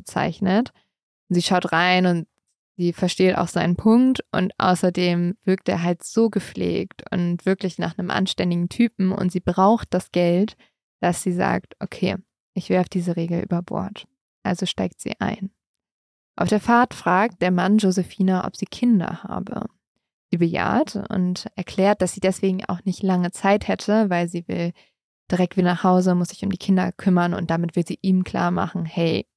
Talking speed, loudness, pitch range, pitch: 175 wpm, -22 LUFS, 175-195 Hz, 185 Hz